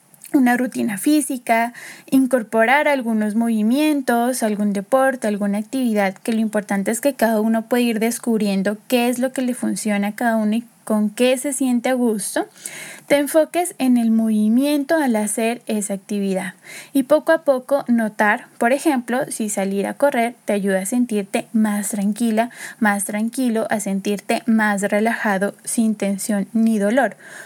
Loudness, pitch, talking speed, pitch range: -19 LUFS, 230 Hz, 155 wpm, 210-260 Hz